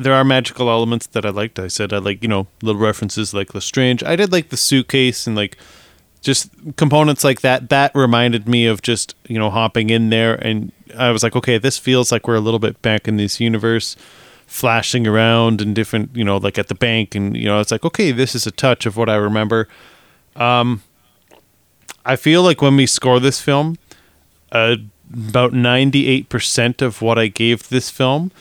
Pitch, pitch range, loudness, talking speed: 115 Hz, 110-130 Hz, -16 LUFS, 205 wpm